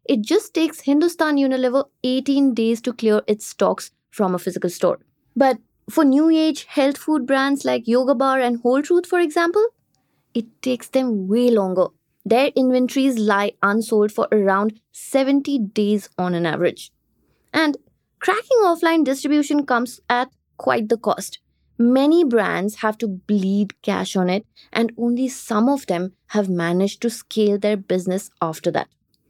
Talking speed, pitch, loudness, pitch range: 155 wpm, 240 Hz, -20 LUFS, 210-280 Hz